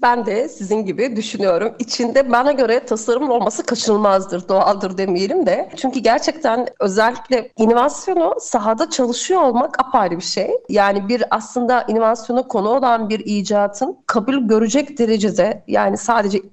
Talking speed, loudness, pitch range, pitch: 135 wpm, -17 LUFS, 210-255 Hz, 230 Hz